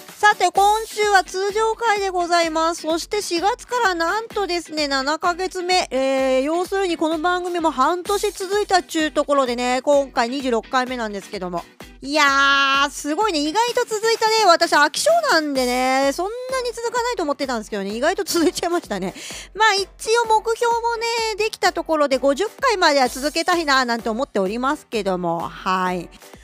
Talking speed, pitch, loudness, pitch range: 355 characters per minute, 330 Hz, -19 LUFS, 270-410 Hz